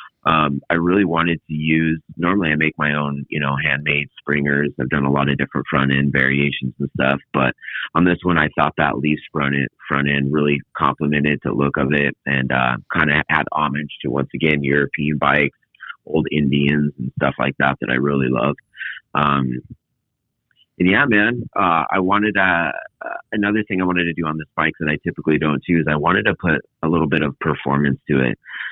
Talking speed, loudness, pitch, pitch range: 205 wpm, -19 LUFS, 75 Hz, 70-80 Hz